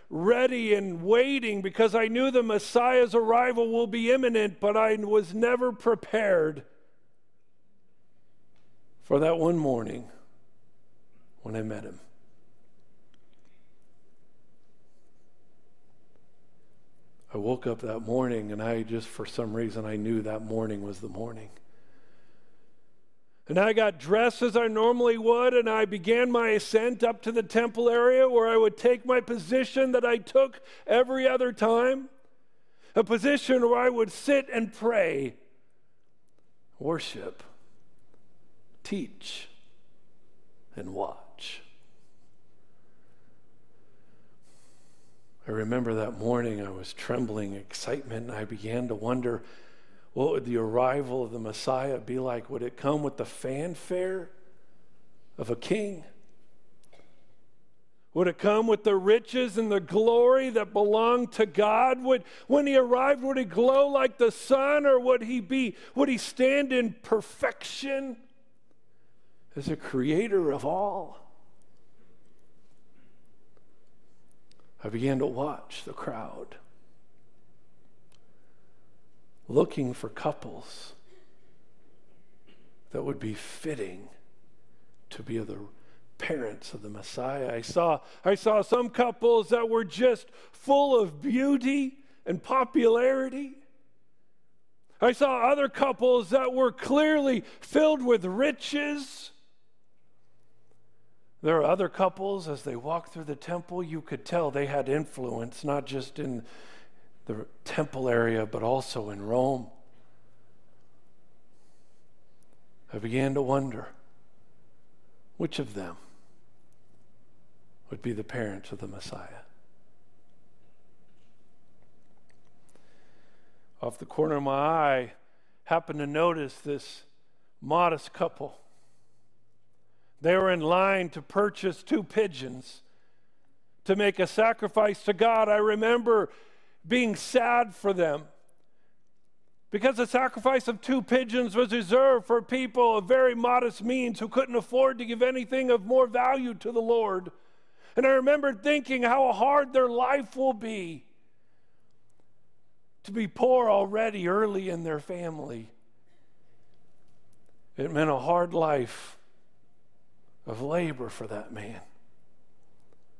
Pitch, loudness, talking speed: 200 Hz, -27 LUFS, 120 wpm